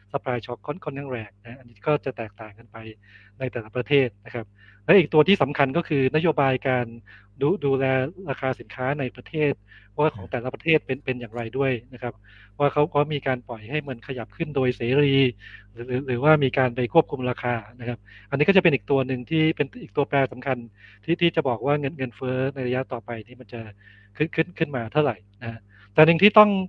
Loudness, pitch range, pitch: -24 LUFS, 115-145 Hz, 130 Hz